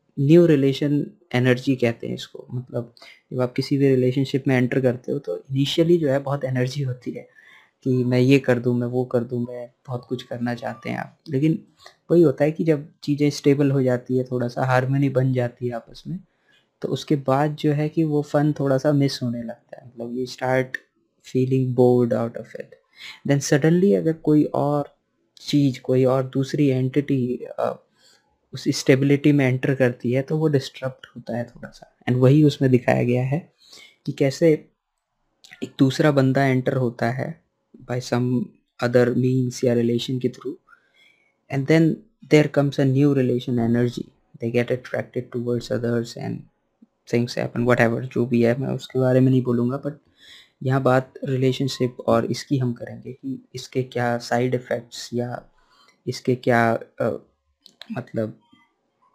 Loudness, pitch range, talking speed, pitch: -22 LUFS, 125-145 Hz, 175 wpm, 130 Hz